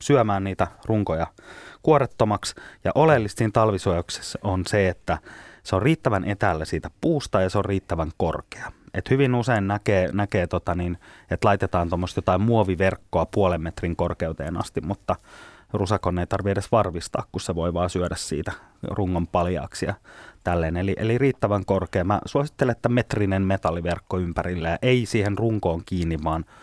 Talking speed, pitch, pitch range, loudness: 150 wpm, 95 Hz, 90-105 Hz, -24 LUFS